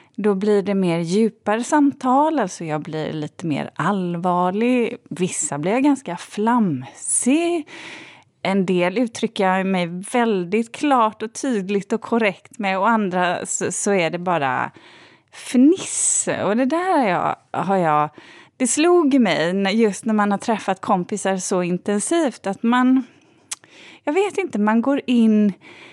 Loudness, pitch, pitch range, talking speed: -20 LUFS, 215 Hz, 185-255 Hz, 140 wpm